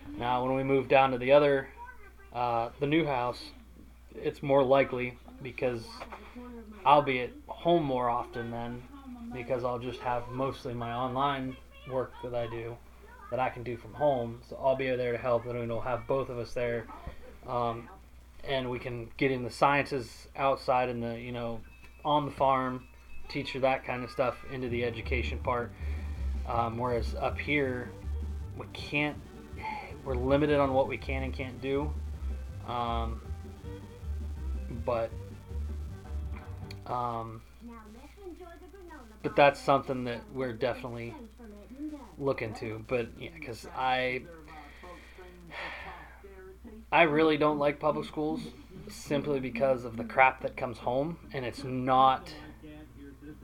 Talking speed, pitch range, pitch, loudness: 140 wpm, 115-140 Hz, 125 Hz, -31 LUFS